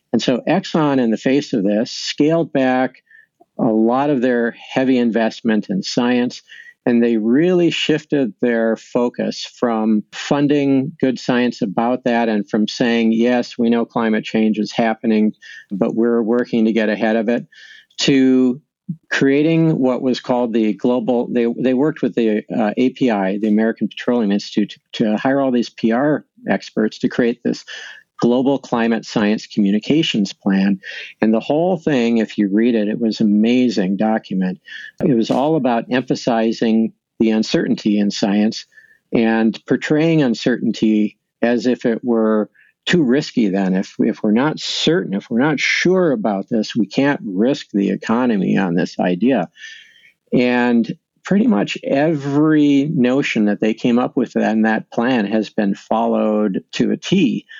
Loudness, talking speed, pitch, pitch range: -17 LUFS, 155 wpm, 120 Hz, 110-135 Hz